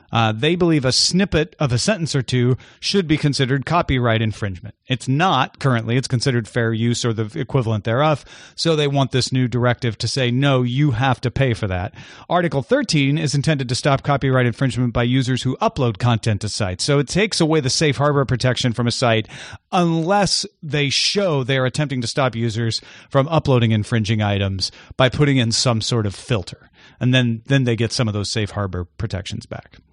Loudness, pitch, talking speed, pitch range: -19 LUFS, 130 Hz, 195 wpm, 115-145 Hz